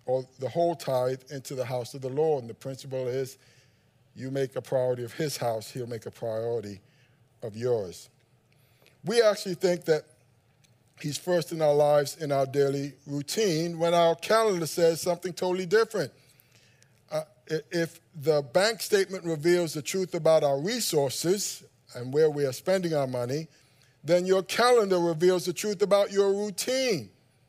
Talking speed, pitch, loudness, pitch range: 160 wpm, 145 Hz, -27 LUFS, 130-175 Hz